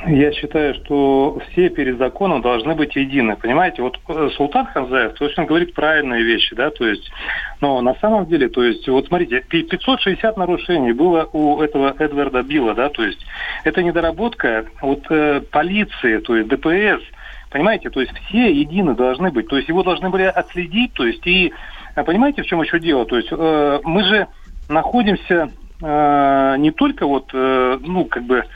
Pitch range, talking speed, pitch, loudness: 140-180 Hz, 170 wpm, 155 Hz, -17 LUFS